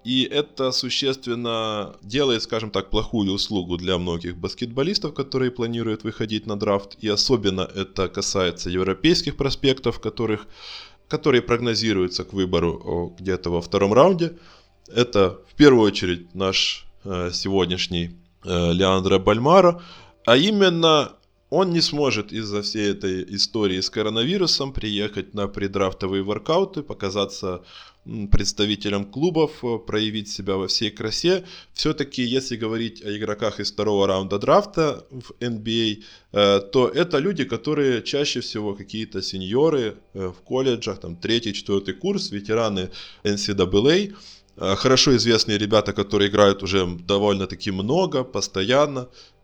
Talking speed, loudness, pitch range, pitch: 120 wpm, -22 LUFS, 95-125 Hz, 105 Hz